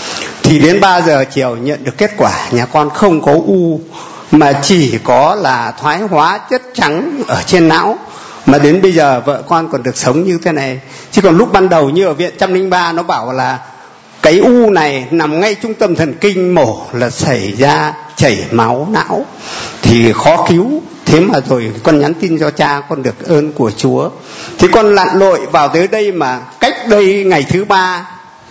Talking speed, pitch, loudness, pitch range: 200 wpm, 160 Hz, -11 LUFS, 140-190 Hz